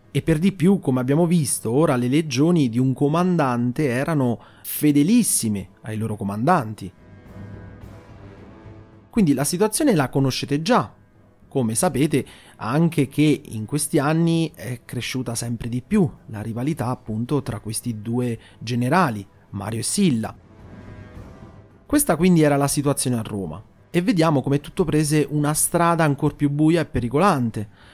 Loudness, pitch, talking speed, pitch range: -21 LUFS, 130 Hz, 140 wpm, 110-150 Hz